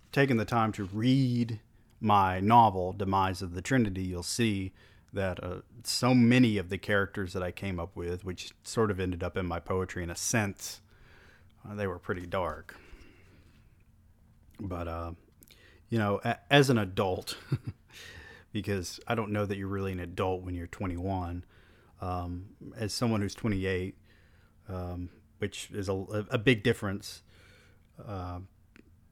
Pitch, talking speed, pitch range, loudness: 100 Hz, 150 wpm, 90-110 Hz, -30 LUFS